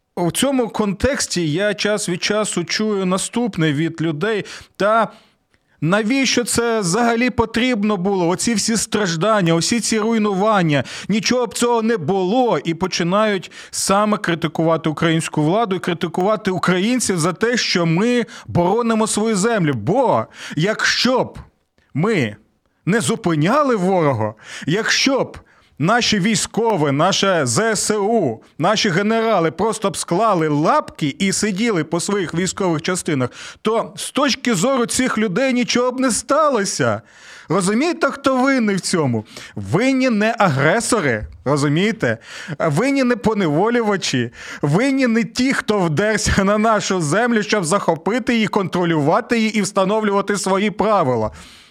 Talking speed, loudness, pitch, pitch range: 125 wpm, -18 LUFS, 205 Hz, 170-230 Hz